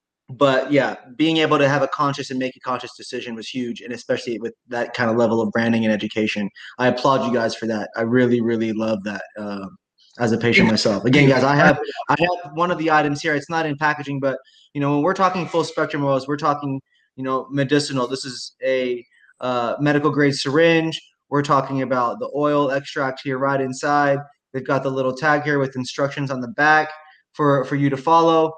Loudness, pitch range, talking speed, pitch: -20 LUFS, 125-150 Hz, 215 wpm, 135 Hz